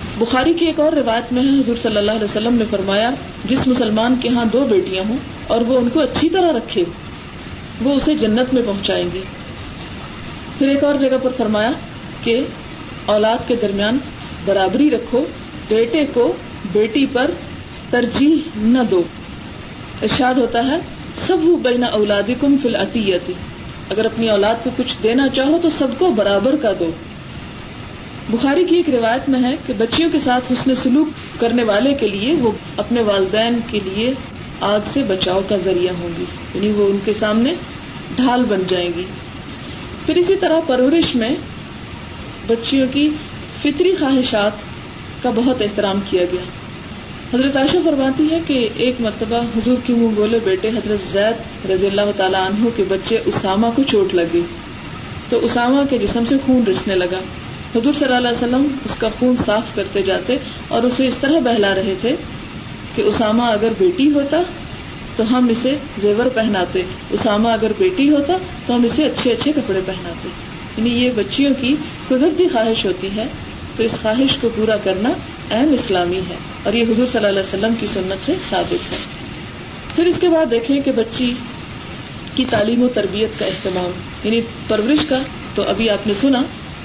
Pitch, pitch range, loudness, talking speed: 235 Hz, 210-270 Hz, -17 LUFS, 170 wpm